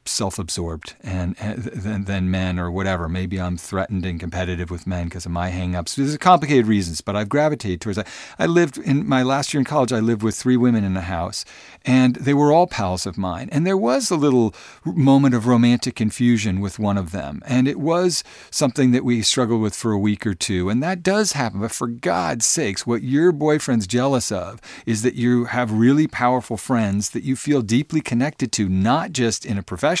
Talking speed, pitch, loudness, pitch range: 215 wpm, 115 Hz, -20 LUFS, 95-130 Hz